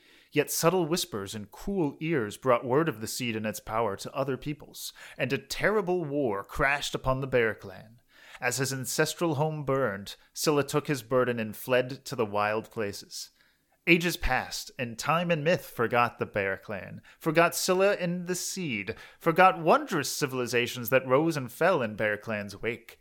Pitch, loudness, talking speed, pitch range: 135 Hz, -28 LUFS, 175 wpm, 120-165 Hz